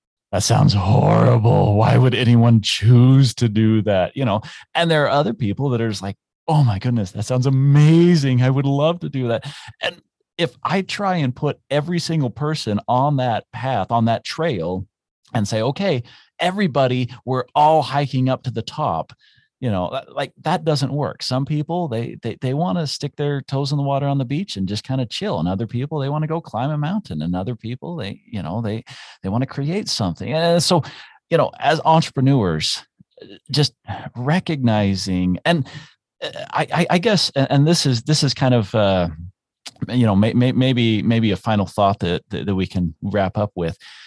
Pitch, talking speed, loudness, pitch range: 130 Hz, 195 wpm, -19 LUFS, 110-150 Hz